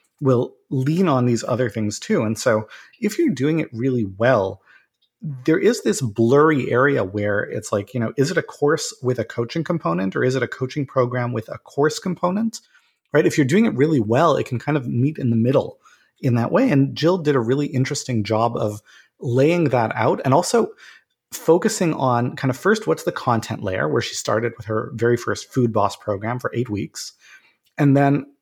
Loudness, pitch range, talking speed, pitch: -20 LUFS, 115-155 Hz, 205 wpm, 130 Hz